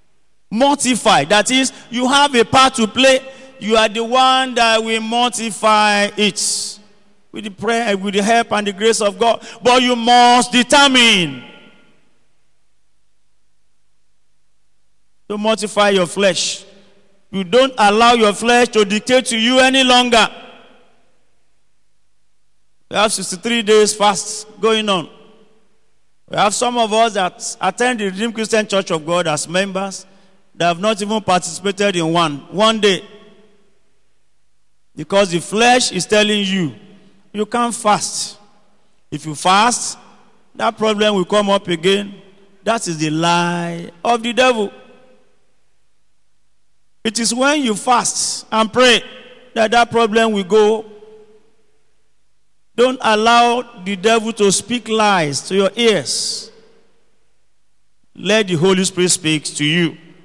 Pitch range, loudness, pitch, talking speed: 195-230 Hz, -15 LUFS, 215 Hz, 135 wpm